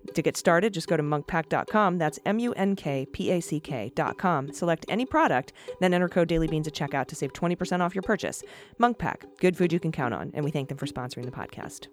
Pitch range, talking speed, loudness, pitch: 145-185 Hz, 230 wpm, -27 LUFS, 170 Hz